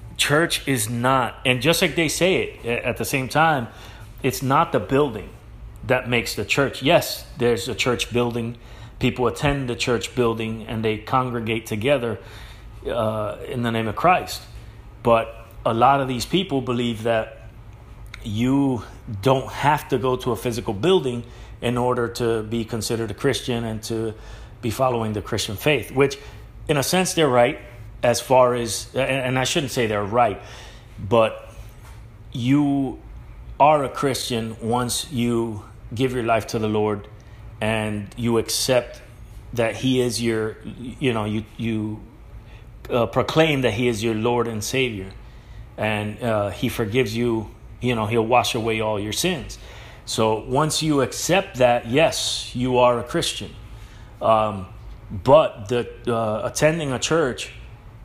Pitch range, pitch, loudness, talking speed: 110-125 Hz, 115 Hz, -22 LUFS, 155 wpm